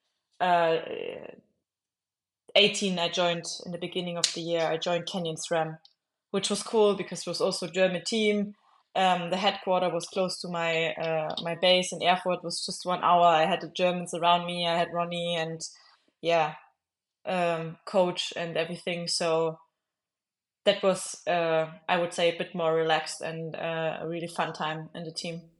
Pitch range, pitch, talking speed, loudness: 165-180 Hz, 170 Hz, 180 wpm, -28 LUFS